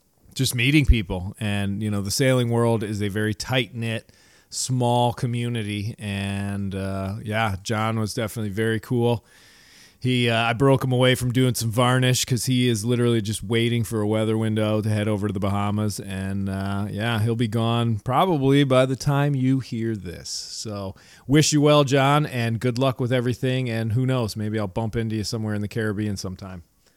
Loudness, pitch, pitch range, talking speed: -23 LUFS, 115 Hz, 105-125 Hz, 190 wpm